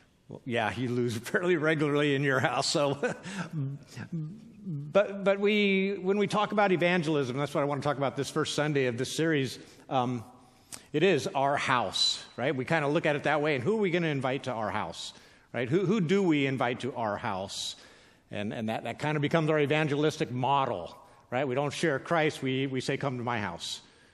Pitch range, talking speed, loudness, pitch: 125-160 Hz, 215 wpm, -29 LUFS, 140 Hz